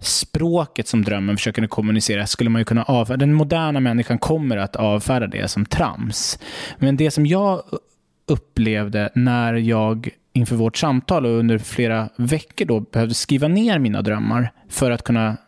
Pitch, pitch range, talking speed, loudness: 115 Hz, 110-135 Hz, 165 wpm, -20 LUFS